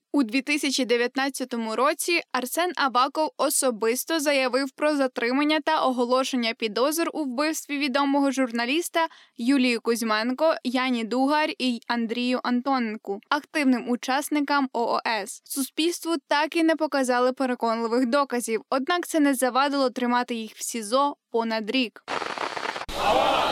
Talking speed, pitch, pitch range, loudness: 110 wpm, 265 Hz, 245-295 Hz, -24 LUFS